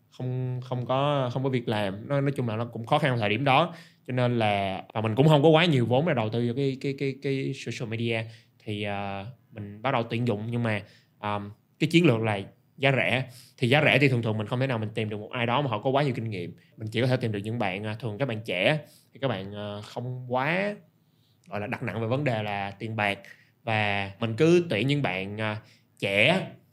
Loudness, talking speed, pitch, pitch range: -27 LUFS, 255 wpm, 120 Hz, 110-135 Hz